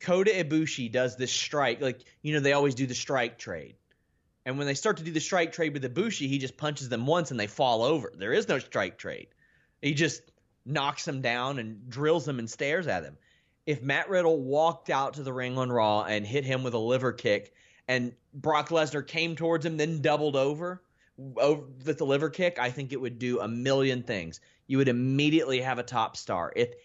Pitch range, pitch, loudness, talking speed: 125-155 Hz, 140 Hz, -29 LUFS, 220 wpm